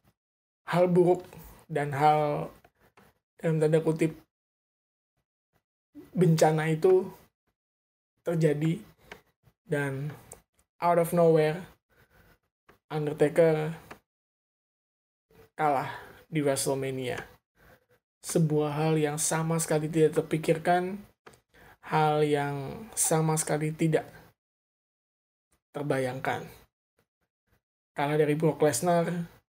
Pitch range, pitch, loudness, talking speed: 145-165 Hz, 155 Hz, -27 LUFS, 70 wpm